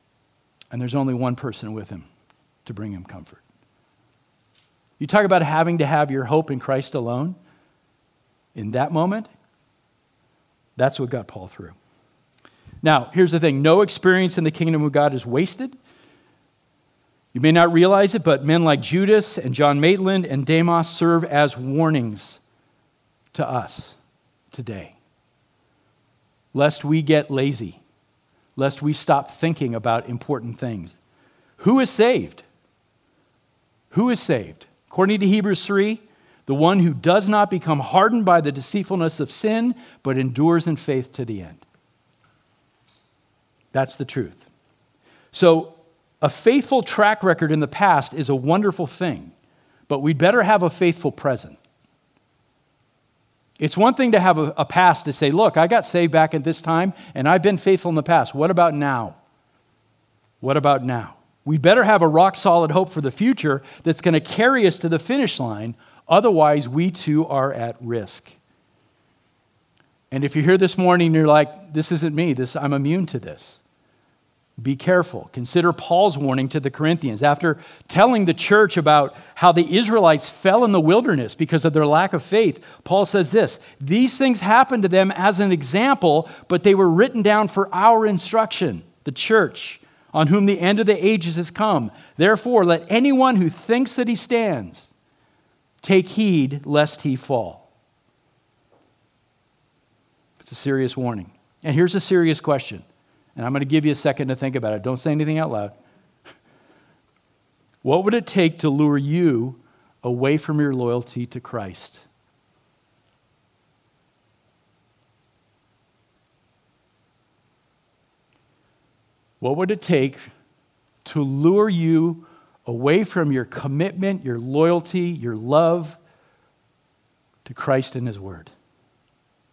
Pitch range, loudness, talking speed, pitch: 135-185 Hz, -19 LUFS, 150 wpm, 155 Hz